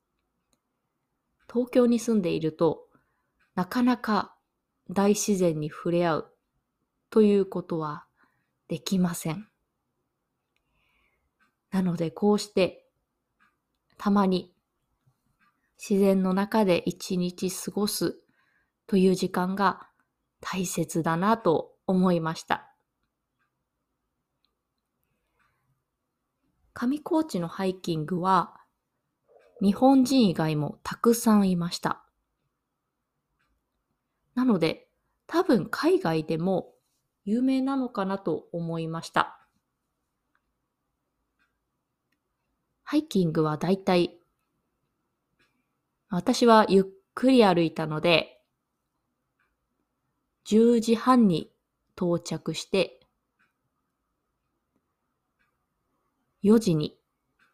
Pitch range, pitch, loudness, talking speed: 165-220 Hz, 190 Hz, -25 LUFS, 150 characters per minute